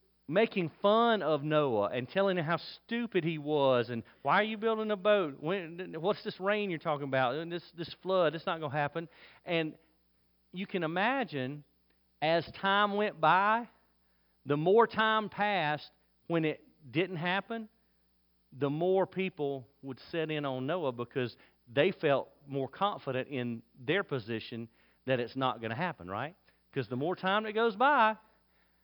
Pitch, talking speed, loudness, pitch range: 160 Hz, 165 wpm, -32 LUFS, 130-195 Hz